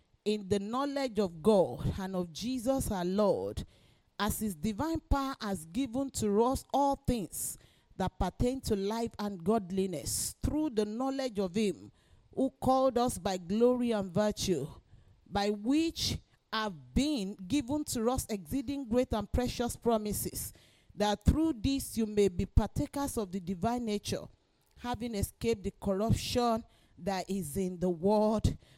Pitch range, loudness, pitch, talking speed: 195-250 Hz, -32 LUFS, 215 Hz, 145 wpm